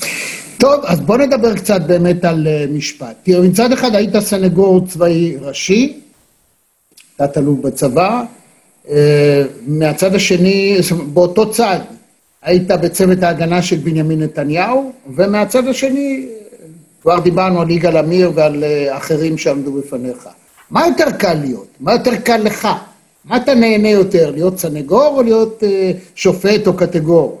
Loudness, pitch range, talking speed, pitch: -13 LUFS, 160-220 Hz, 125 wpm, 180 Hz